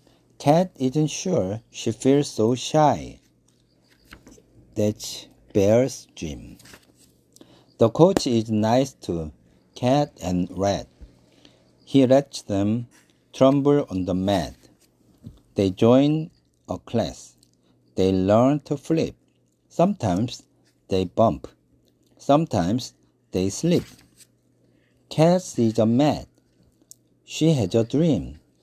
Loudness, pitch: -22 LUFS, 110 Hz